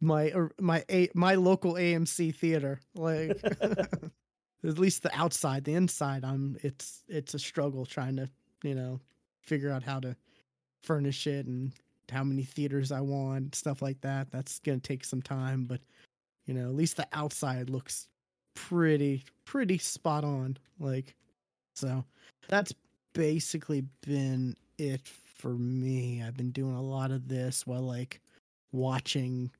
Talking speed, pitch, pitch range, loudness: 150 wpm, 140 Hz, 130-160 Hz, -32 LUFS